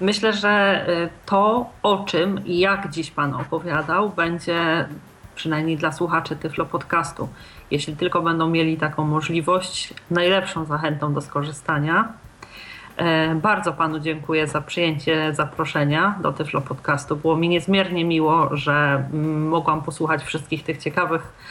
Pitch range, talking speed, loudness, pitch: 155-175 Hz, 125 wpm, -21 LUFS, 160 Hz